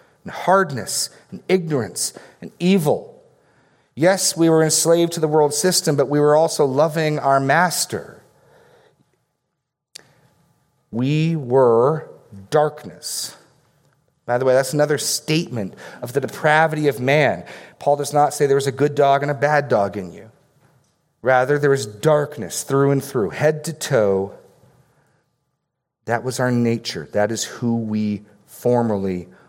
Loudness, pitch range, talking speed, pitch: -19 LUFS, 130-155 Hz, 140 wpm, 145 Hz